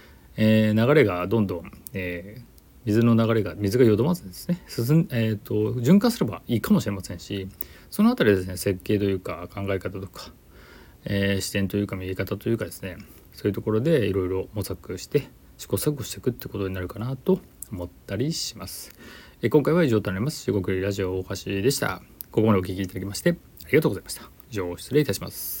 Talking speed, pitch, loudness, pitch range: 420 characters per minute, 100 Hz, -25 LUFS, 95-120 Hz